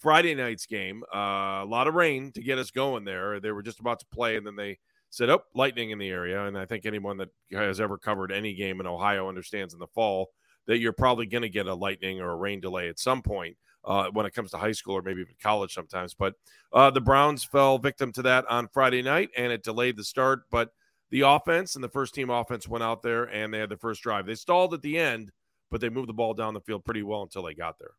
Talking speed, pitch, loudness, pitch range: 265 wpm, 110 Hz, -27 LUFS, 100-130 Hz